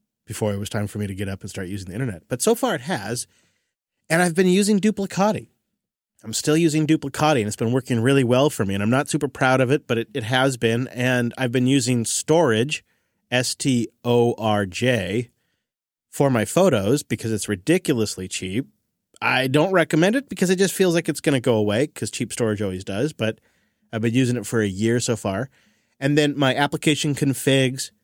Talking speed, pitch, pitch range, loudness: 210 wpm, 130 Hz, 110-150 Hz, -21 LUFS